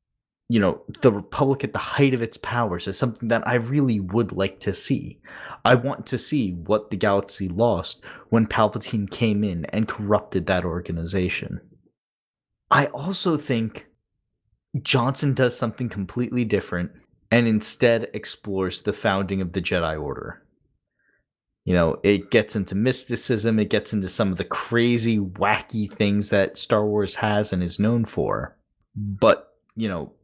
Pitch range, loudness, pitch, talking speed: 95-120 Hz, -23 LUFS, 105 Hz, 155 wpm